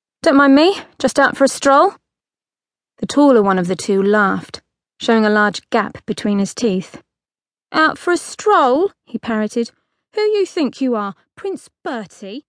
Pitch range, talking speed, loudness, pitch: 210-320 Hz, 170 wpm, -16 LUFS, 260 Hz